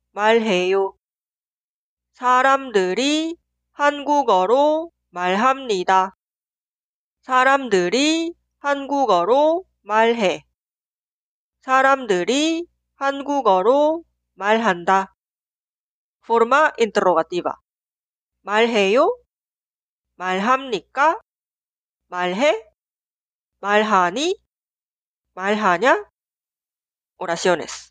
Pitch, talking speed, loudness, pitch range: 230 Hz, 160 characters per minute, -19 LUFS, 190-285 Hz